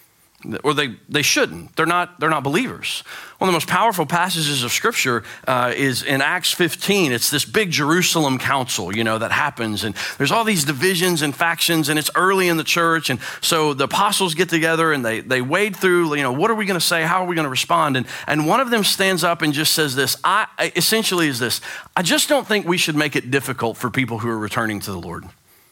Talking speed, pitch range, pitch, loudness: 235 wpm, 130-180 Hz, 155 Hz, -18 LUFS